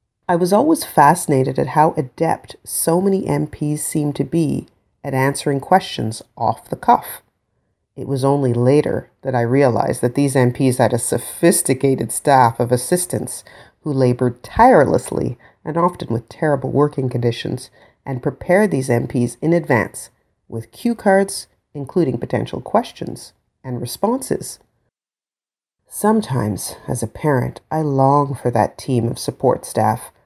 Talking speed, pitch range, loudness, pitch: 140 wpm, 120-155 Hz, -18 LUFS, 135 Hz